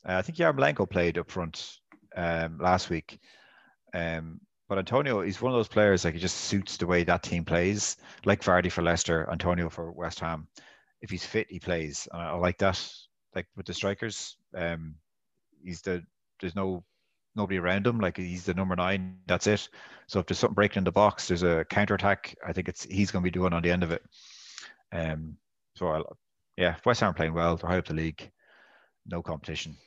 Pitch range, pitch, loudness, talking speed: 85-95 Hz, 90 Hz, -29 LUFS, 205 wpm